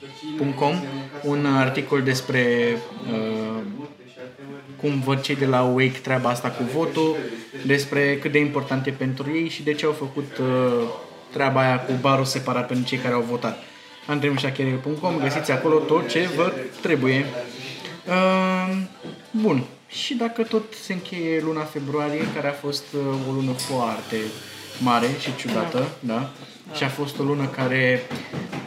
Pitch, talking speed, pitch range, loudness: 140 Hz, 150 wpm, 130-150 Hz, -23 LUFS